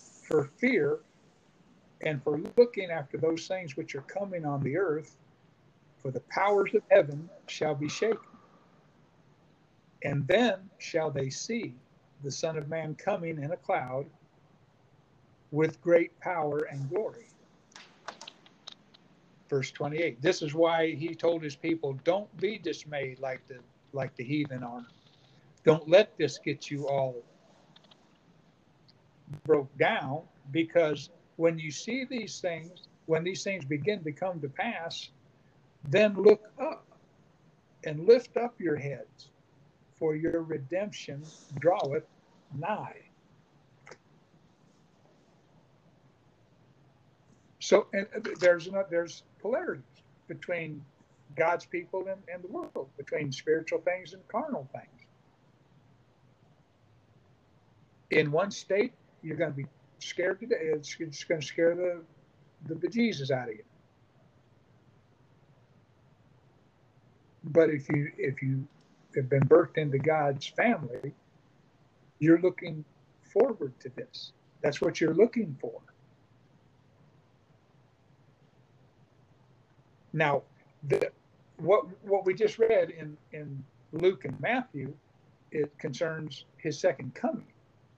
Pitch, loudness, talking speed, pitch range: 150 Hz, -30 LUFS, 115 wpm, 135-170 Hz